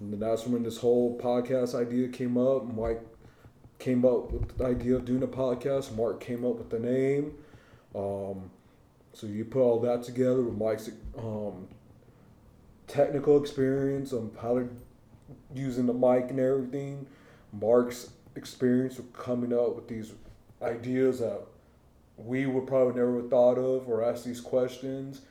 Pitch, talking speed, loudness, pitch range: 125 Hz, 155 wpm, -29 LUFS, 115-130 Hz